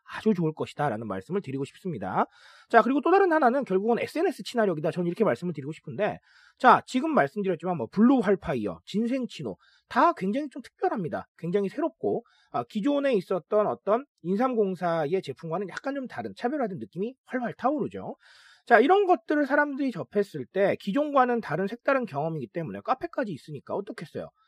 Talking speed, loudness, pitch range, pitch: 410 characters per minute, -27 LUFS, 180-275 Hz, 220 Hz